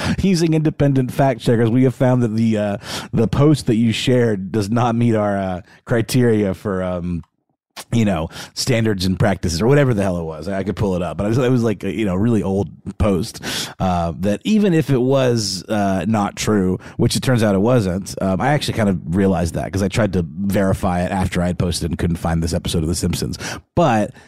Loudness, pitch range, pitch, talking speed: -18 LUFS, 95-120 Hz, 105 Hz, 220 wpm